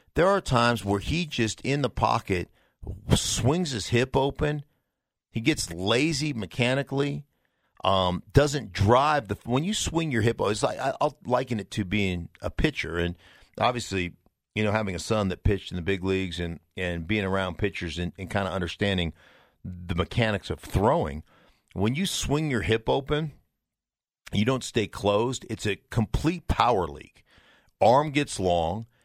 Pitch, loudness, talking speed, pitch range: 110 Hz, -26 LUFS, 165 wpm, 95-130 Hz